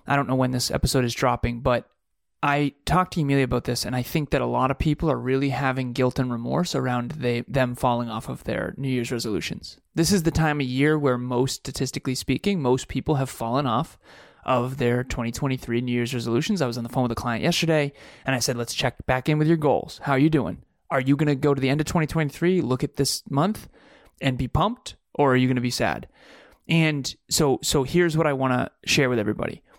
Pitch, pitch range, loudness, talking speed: 135 Hz, 125-150 Hz, -24 LUFS, 240 wpm